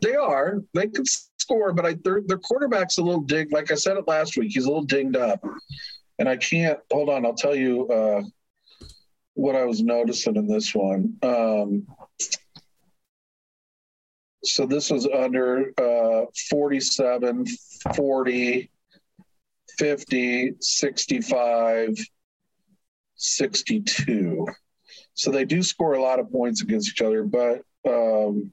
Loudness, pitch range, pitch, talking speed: -23 LUFS, 125-185 Hz, 140 Hz, 135 wpm